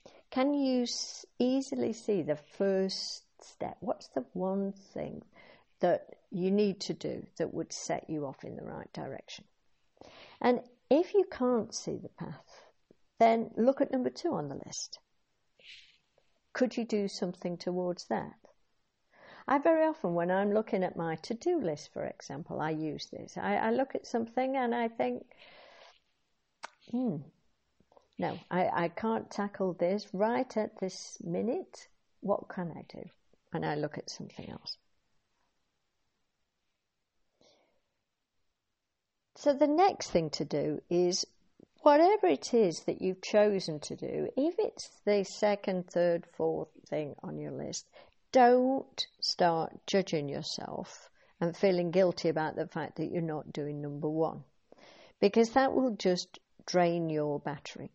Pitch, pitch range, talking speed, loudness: 200 Hz, 175-245 Hz, 145 wpm, -32 LUFS